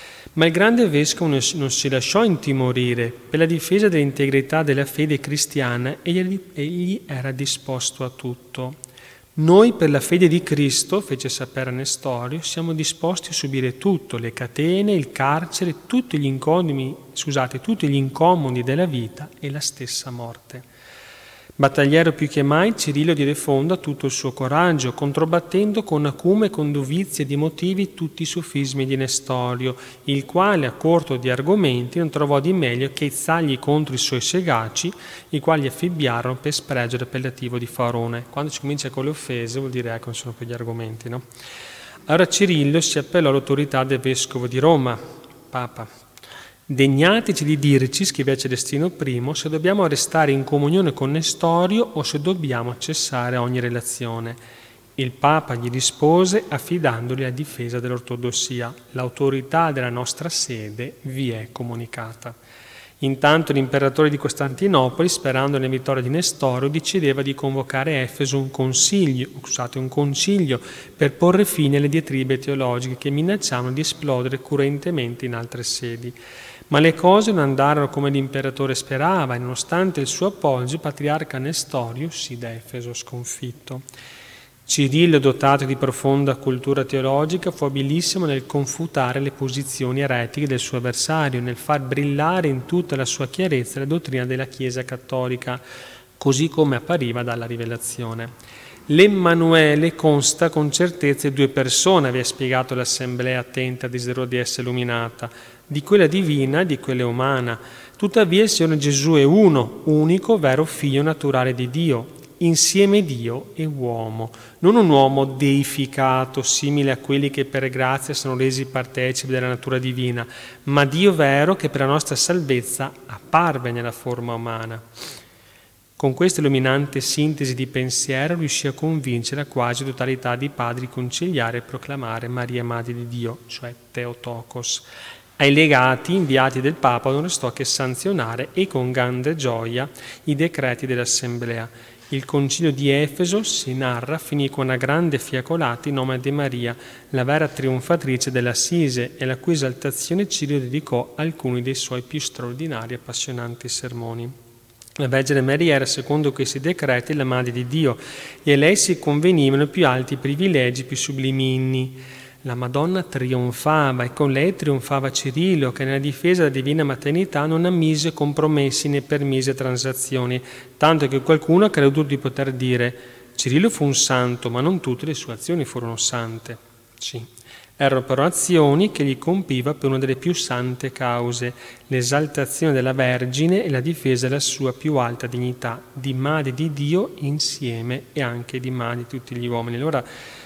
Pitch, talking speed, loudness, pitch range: 135 Hz, 150 wpm, -20 LUFS, 125-155 Hz